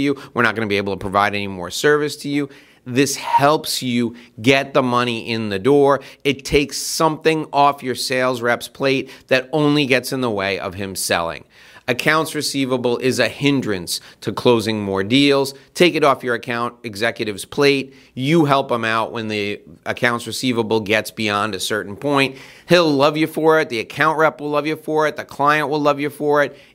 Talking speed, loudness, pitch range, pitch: 200 wpm, -18 LUFS, 115-145 Hz, 130 Hz